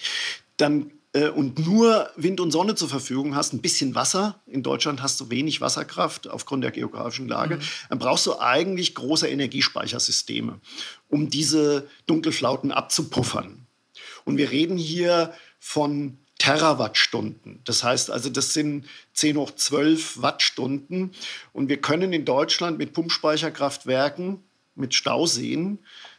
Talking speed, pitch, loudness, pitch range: 130 wpm, 150 Hz, -23 LUFS, 140-175 Hz